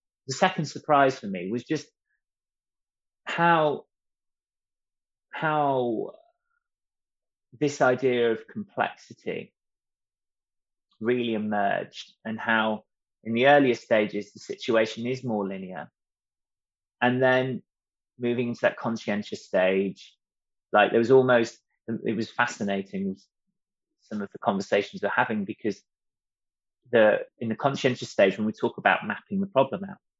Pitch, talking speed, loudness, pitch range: 125 Hz, 120 wpm, -25 LUFS, 110-150 Hz